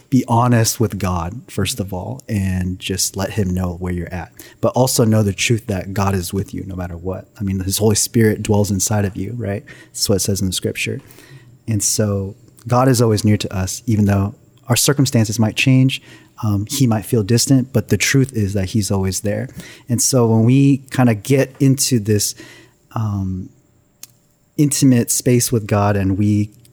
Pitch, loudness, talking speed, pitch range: 110 Hz, -17 LUFS, 200 wpm, 100-125 Hz